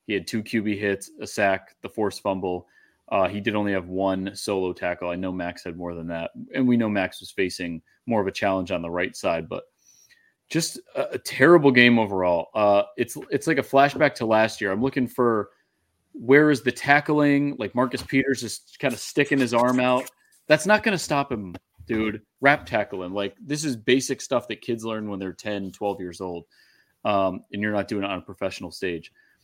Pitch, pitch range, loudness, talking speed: 110 Hz, 95-135 Hz, -24 LUFS, 215 wpm